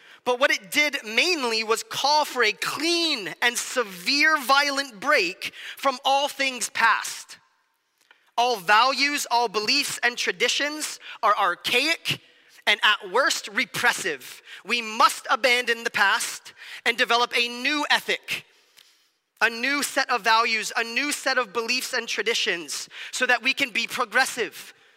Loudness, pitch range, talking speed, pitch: -22 LUFS, 235-285 Hz, 140 wpm, 260 Hz